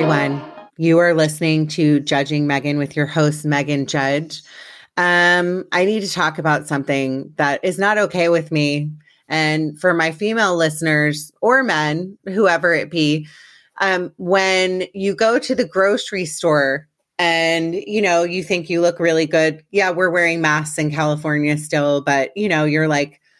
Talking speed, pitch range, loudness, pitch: 165 wpm, 150-180 Hz, -17 LUFS, 160 Hz